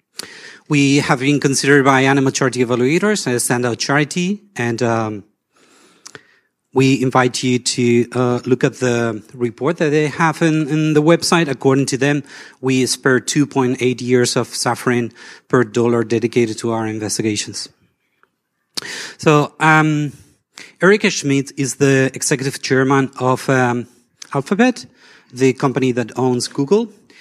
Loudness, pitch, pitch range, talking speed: -16 LUFS, 130 Hz, 120-145 Hz, 135 wpm